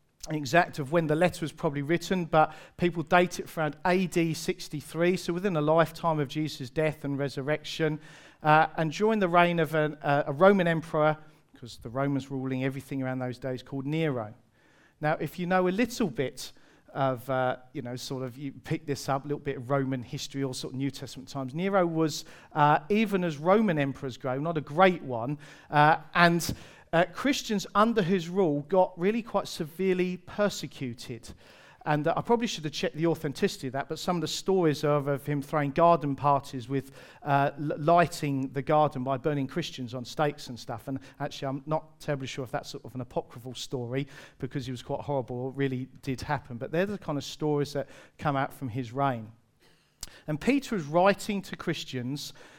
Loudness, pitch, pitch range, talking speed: -28 LUFS, 150 Hz, 135-170 Hz, 195 wpm